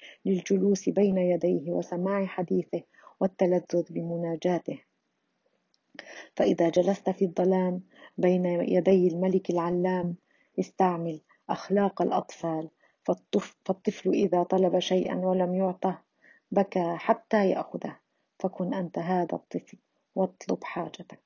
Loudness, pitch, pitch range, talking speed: -28 LUFS, 185 Hz, 175-190 Hz, 95 wpm